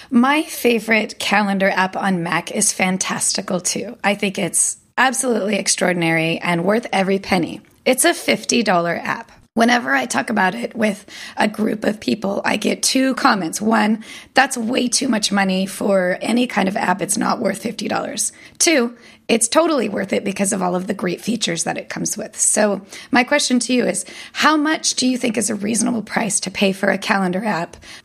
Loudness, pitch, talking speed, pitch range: -18 LUFS, 215 Hz, 190 wpm, 195-245 Hz